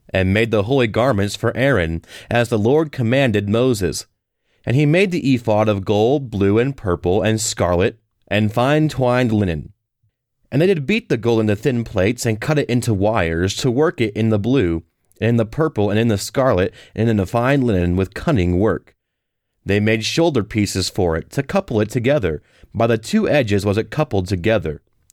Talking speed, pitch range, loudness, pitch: 195 wpm, 100-130 Hz, -18 LUFS, 110 Hz